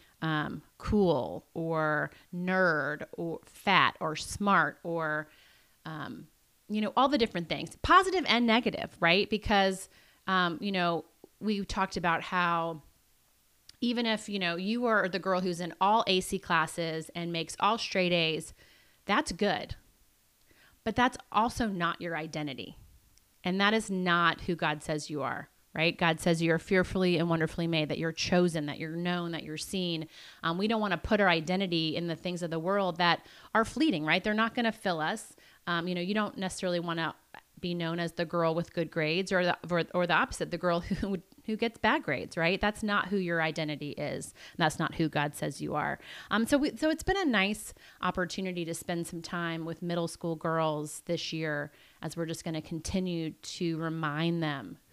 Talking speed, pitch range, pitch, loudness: 190 wpm, 165-200 Hz, 175 Hz, -30 LUFS